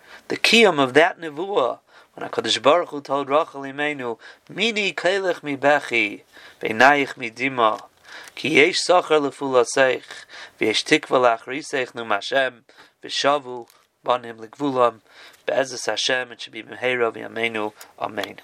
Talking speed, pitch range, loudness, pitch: 135 wpm, 120-145 Hz, -20 LUFS, 135 Hz